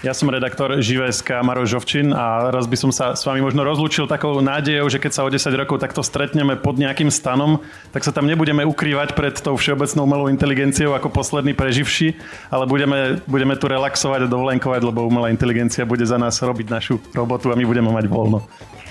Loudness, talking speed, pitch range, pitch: -18 LUFS, 195 wpm, 125-145 Hz, 135 Hz